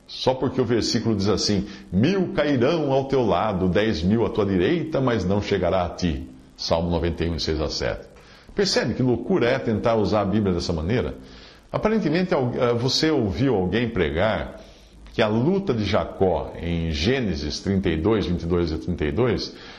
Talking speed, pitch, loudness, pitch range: 155 wpm, 105 Hz, -23 LUFS, 85-130 Hz